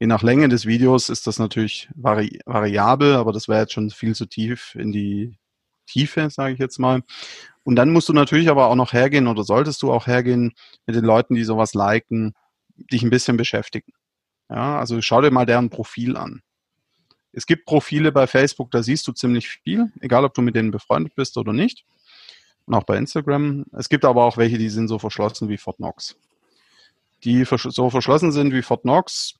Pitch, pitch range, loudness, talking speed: 120 Hz, 110-135 Hz, -19 LUFS, 200 wpm